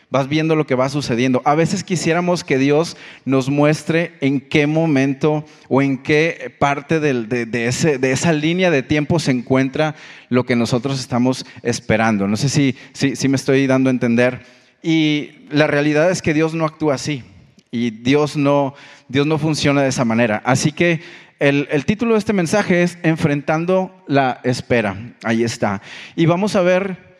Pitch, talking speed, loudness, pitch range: 145 Hz, 180 wpm, -17 LUFS, 130-160 Hz